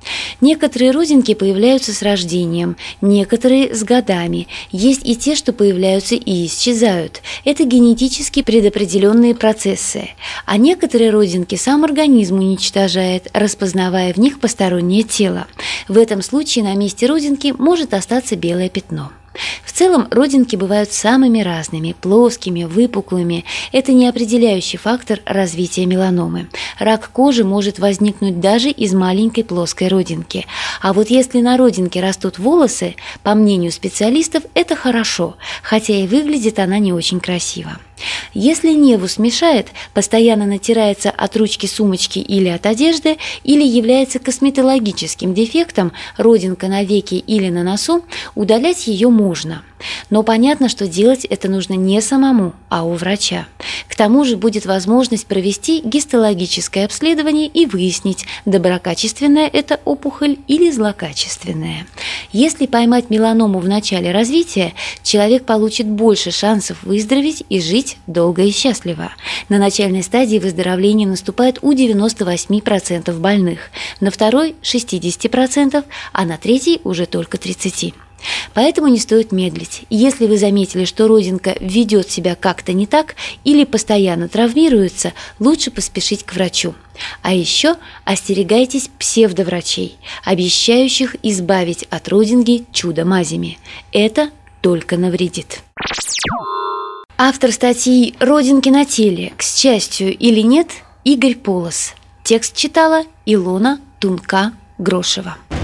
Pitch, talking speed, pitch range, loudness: 210 Hz, 120 wpm, 185-255 Hz, -14 LUFS